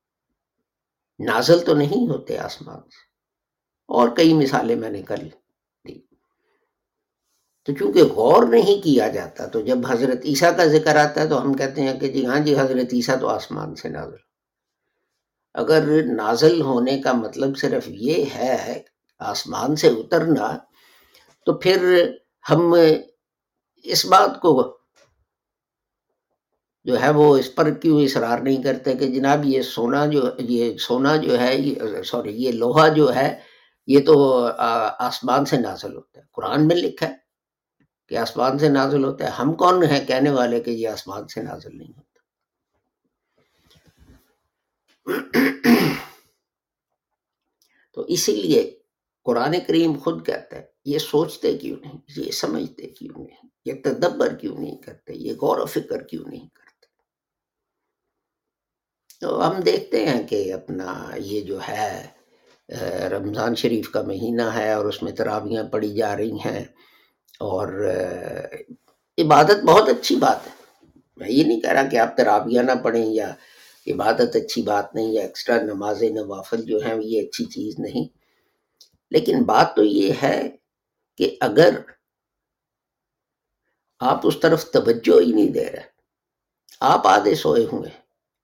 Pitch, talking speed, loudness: 145 Hz, 145 wpm, -20 LUFS